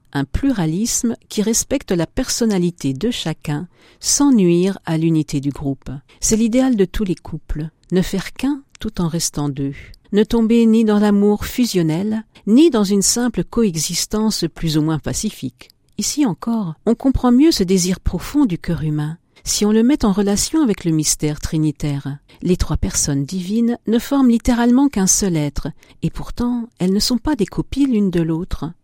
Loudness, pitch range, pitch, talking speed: -18 LUFS, 160-230 Hz, 190 Hz, 175 wpm